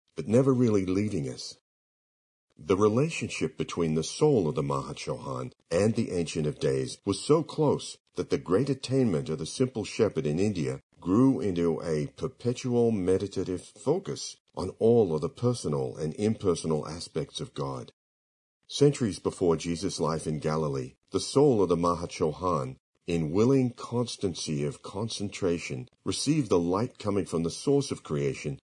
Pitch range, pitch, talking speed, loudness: 80-125 Hz, 100 Hz, 155 wpm, -28 LUFS